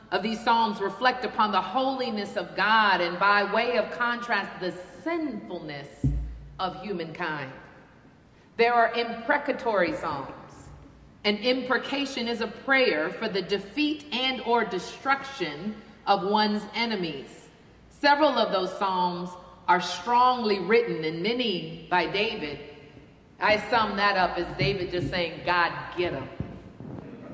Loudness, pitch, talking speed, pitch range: -26 LUFS, 205 Hz, 125 wpm, 180-235 Hz